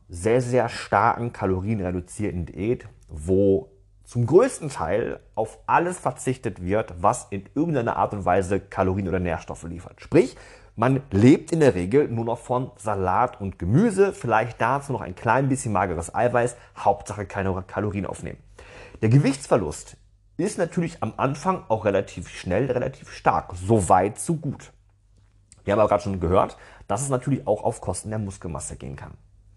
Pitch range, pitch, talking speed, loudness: 95-125 Hz, 105 Hz, 160 wpm, -24 LUFS